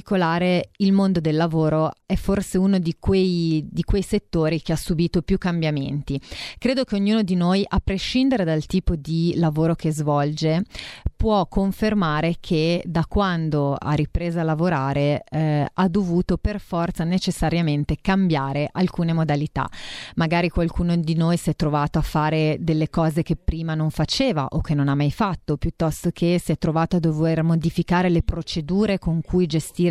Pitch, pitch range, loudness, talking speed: 170 Hz, 155-185 Hz, -22 LUFS, 165 wpm